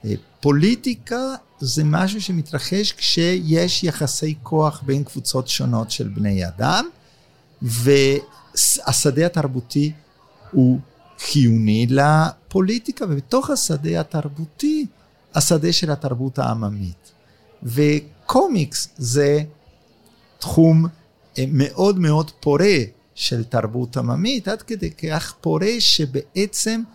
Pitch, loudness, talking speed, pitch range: 150 Hz, -19 LUFS, 85 wpm, 135-180 Hz